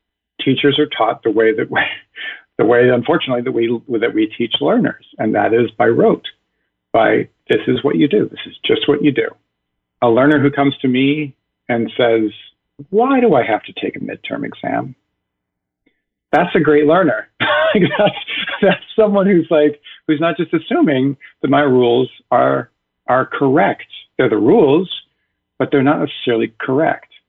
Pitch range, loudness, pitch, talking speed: 115-170 Hz, -15 LUFS, 140 Hz, 170 wpm